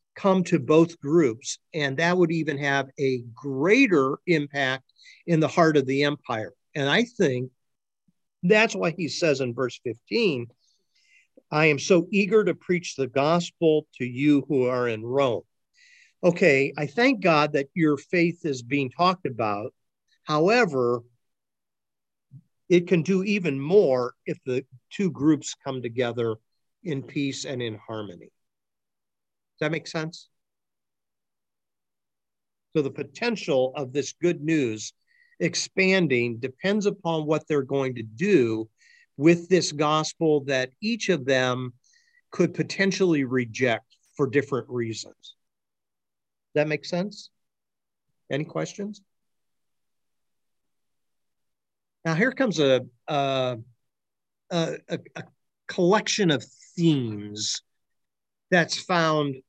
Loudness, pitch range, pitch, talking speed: -24 LUFS, 130-175 Hz, 150 Hz, 120 wpm